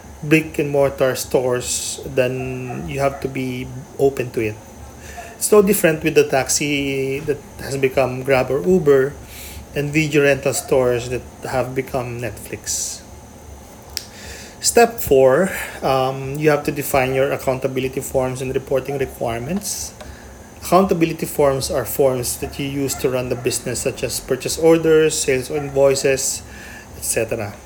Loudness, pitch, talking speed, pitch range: -19 LUFS, 135 Hz, 140 wpm, 130-145 Hz